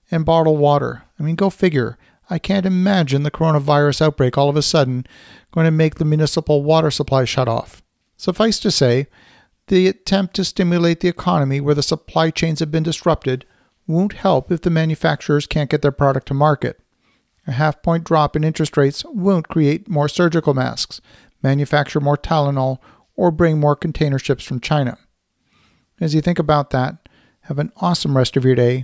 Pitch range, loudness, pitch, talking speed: 140-170 Hz, -18 LUFS, 155 Hz, 180 wpm